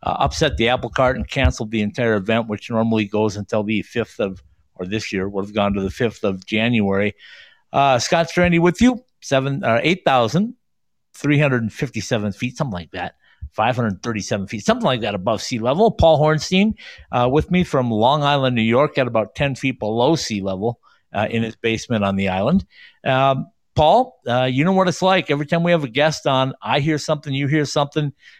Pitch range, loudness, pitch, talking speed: 110-155 Hz, -19 LUFS, 125 Hz, 215 wpm